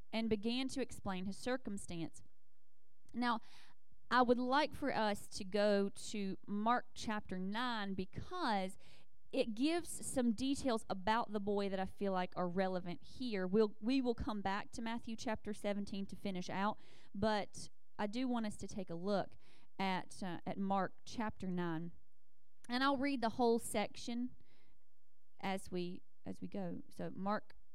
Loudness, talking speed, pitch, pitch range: -40 LUFS, 160 wpm, 210 Hz, 190-235 Hz